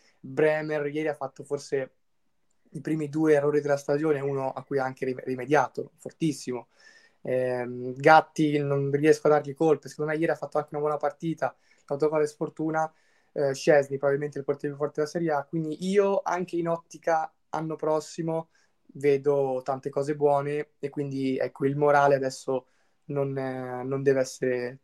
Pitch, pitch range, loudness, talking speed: 145 Hz, 135-155 Hz, -27 LUFS, 165 wpm